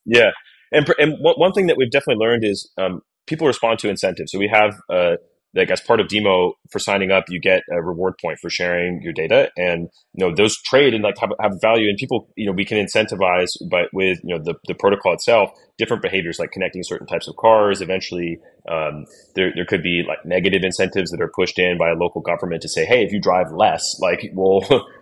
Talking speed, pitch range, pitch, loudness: 230 wpm, 90-115 Hz, 95 Hz, -18 LUFS